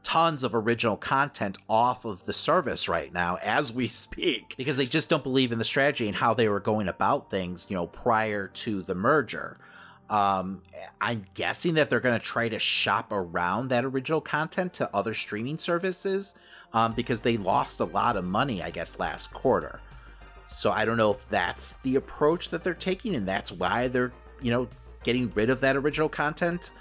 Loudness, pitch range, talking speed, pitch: -27 LUFS, 105-150 Hz, 195 wpm, 120 Hz